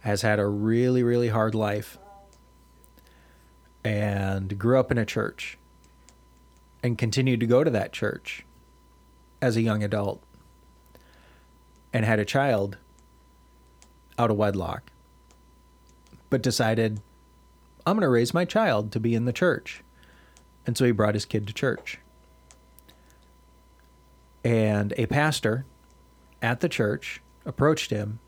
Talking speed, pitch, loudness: 125 wpm, 90 Hz, -25 LUFS